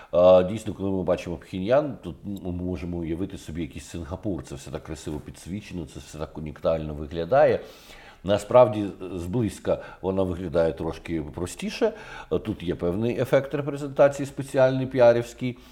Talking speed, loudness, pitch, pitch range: 135 wpm, -25 LUFS, 90 Hz, 85-120 Hz